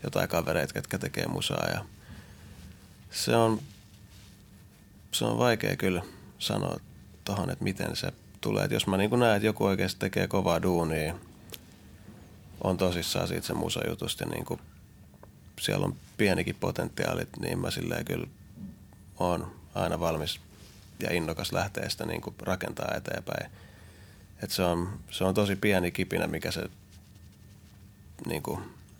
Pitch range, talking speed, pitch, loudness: 90-100 Hz, 130 wpm, 95 Hz, -30 LUFS